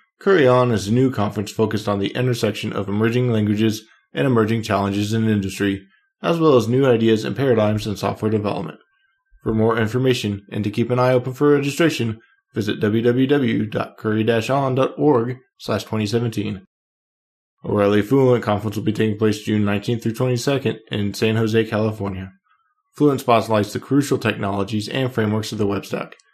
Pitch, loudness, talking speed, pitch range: 110 Hz, -20 LUFS, 155 wpm, 105-125 Hz